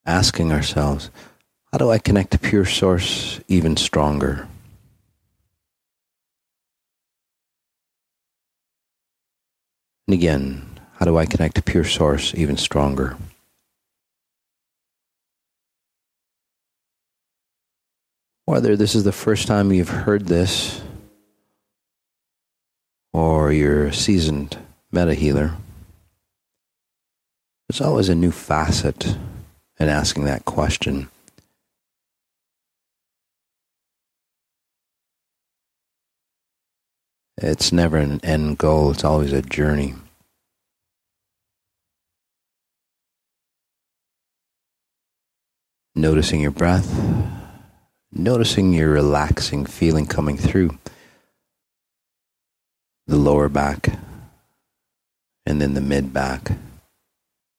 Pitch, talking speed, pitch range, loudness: 85 Hz, 75 wpm, 75-100 Hz, -19 LUFS